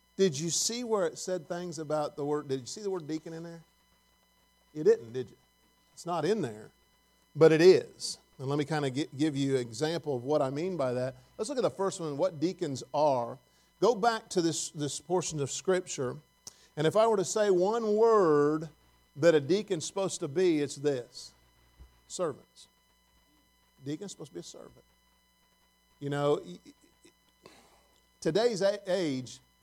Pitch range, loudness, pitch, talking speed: 145-185 Hz, -30 LUFS, 160 Hz, 180 wpm